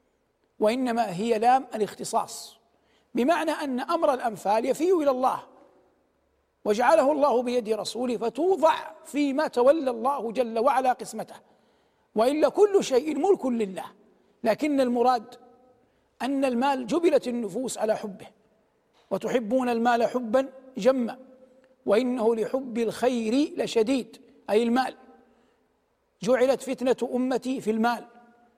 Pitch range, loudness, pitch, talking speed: 230-265 Hz, -25 LUFS, 250 Hz, 105 wpm